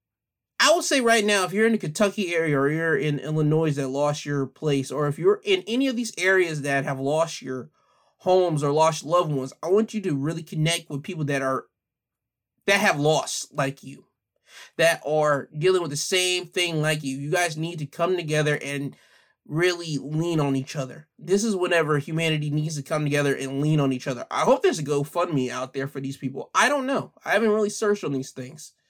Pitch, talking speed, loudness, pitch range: 155 Hz, 220 wpm, -24 LUFS, 140-180 Hz